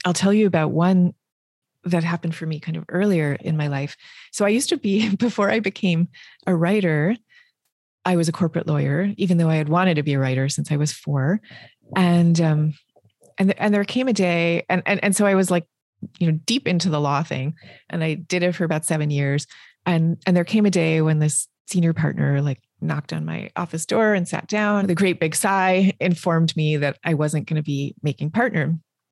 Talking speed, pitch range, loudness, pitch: 220 wpm, 155-190 Hz, -21 LUFS, 170 Hz